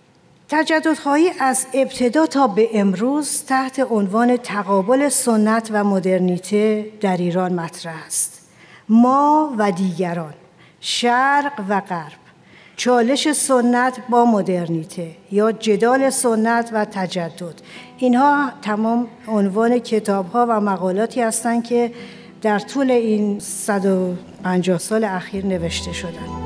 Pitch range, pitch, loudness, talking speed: 185-245 Hz, 215 Hz, -18 LUFS, 110 wpm